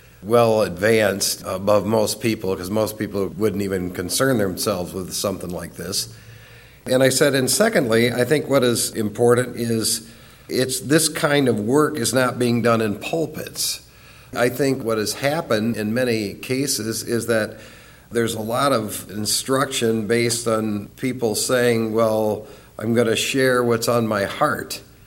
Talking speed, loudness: 160 wpm, -20 LUFS